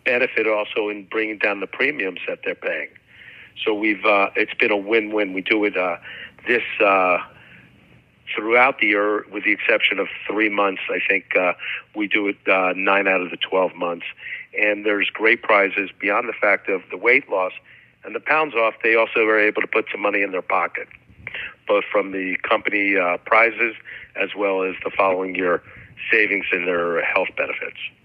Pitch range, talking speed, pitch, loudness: 95-115 Hz, 190 wpm, 105 Hz, -20 LUFS